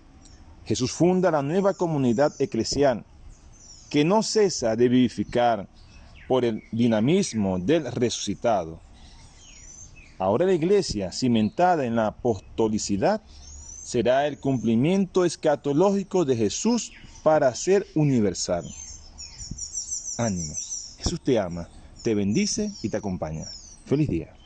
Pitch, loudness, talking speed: 115 Hz, -24 LUFS, 105 wpm